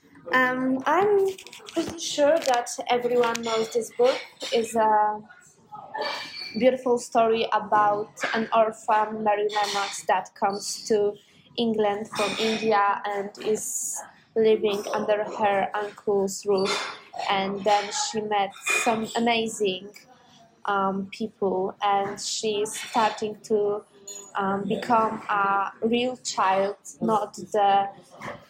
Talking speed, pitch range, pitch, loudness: 105 wpm, 205-235 Hz, 215 Hz, -25 LUFS